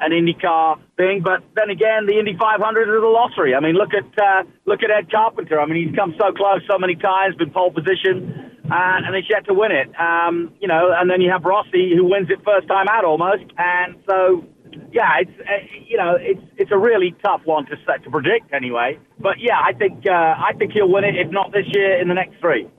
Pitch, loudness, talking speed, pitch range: 190 Hz, -17 LUFS, 240 wpm, 180-210 Hz